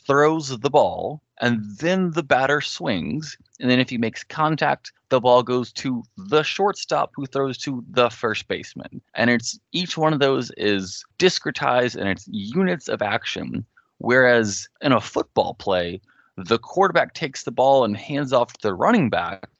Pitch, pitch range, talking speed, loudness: 135 Hz, 120-155 Hz, 170 wpm, -21 LUFS